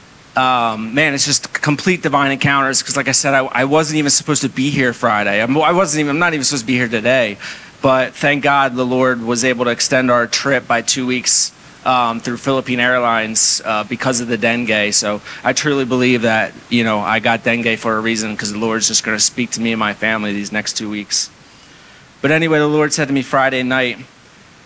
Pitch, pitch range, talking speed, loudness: 125 Hz, 115-140 Hz, 225 wpm, -15 LUFS